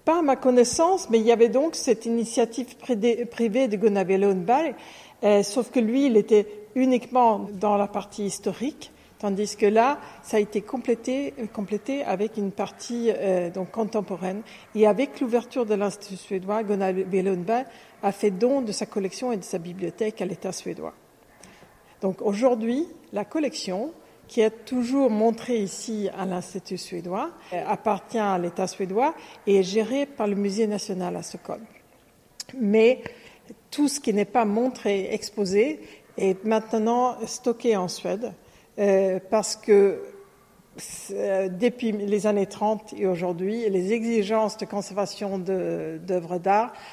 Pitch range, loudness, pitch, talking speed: 195-240 Hz, -25 LUFS, 215 Hz, 145 wpm